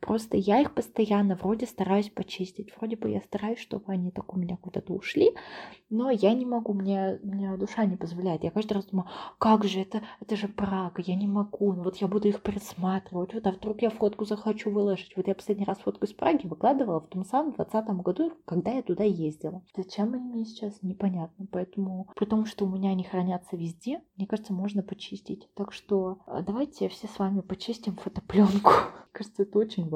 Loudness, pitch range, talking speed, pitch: -29 LUFS, 190-215 Hz, 200 wpm, 200 Hz